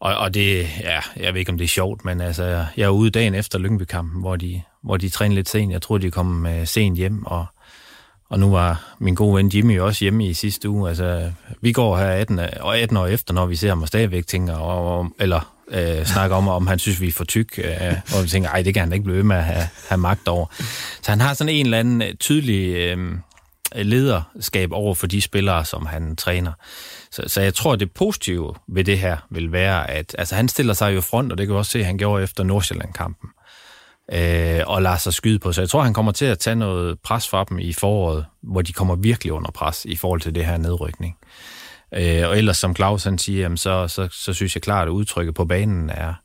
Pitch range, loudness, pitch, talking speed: 85-105 Hz, -20 LUFS, 95 Hz, 240 wpm